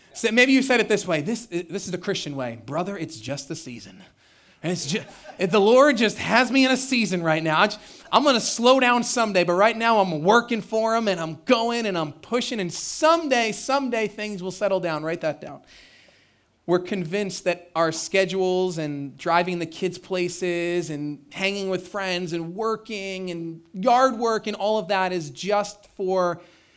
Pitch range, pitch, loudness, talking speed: 170-225 Hz, 190 Hz, -23 LUFS, 190 wpm